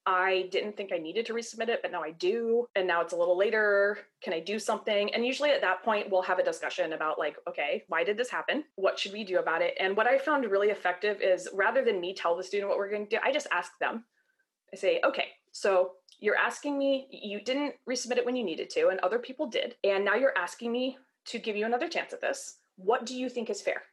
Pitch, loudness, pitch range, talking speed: 220 Hz, -30 LUFS, 190-260 Hz, 260 wpm